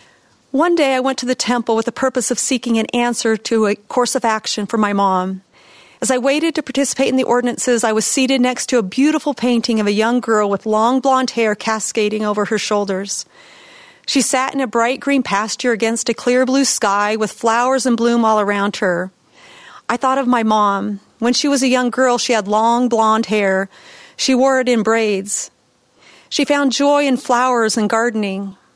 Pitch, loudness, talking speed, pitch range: 235 Hz, -16 LUFS, 200 wpm, 215-260 Hz